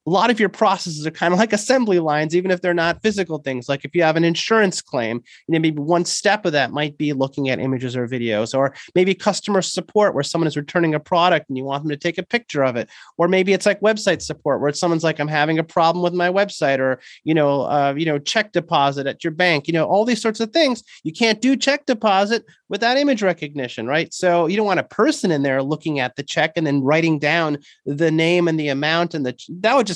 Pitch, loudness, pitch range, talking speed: 165 Hz, -19 LUFS, 145-190 Hz, 255 wpm